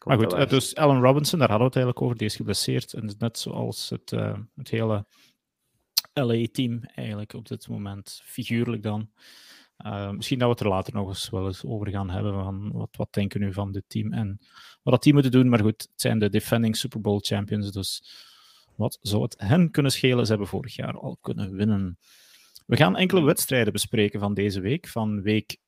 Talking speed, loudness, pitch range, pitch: 205 wpm, -25 LUFS, 100-125 Hz, 110 Hz